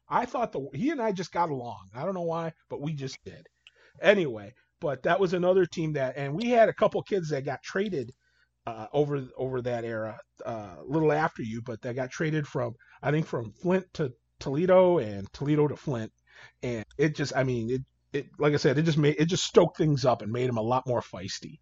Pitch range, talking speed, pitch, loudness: 125-165 Hz, 230 wpm, 145 Hz, -28 LUFS